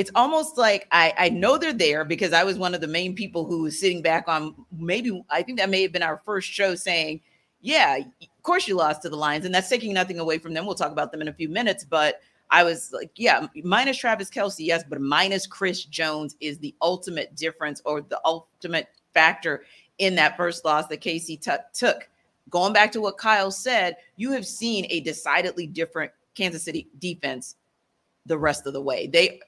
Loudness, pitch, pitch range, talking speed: -23 LUFS, 175 Hz, 160-195 Hz, 215 wpm